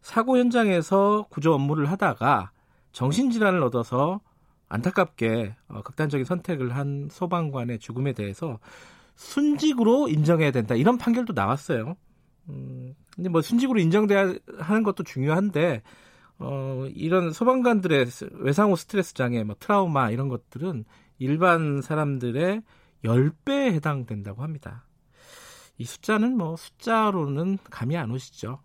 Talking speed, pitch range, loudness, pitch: 295 characters per minute, 130-195 Hz, -24 LUFS, 155 Hz